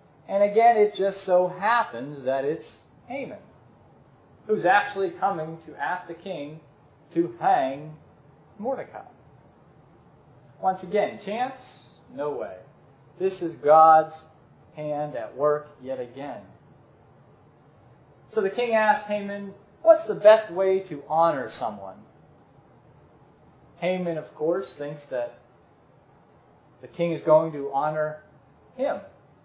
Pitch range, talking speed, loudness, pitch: 150-195 Hz, 115 wpm, -24 LUFS, 165 Hz